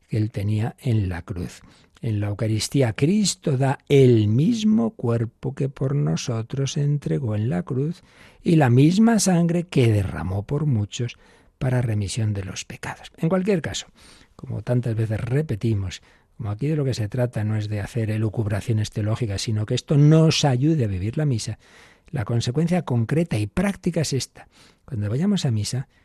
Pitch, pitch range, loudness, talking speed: 125 Hz, 110-150 Hz, -22 LUFS, 170 wpm